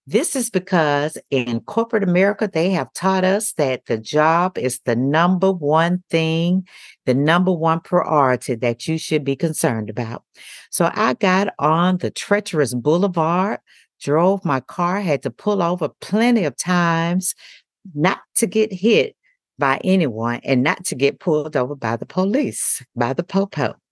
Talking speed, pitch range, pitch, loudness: 160 wpm, 140-190 Hz, 165 Hz, -19 LUFS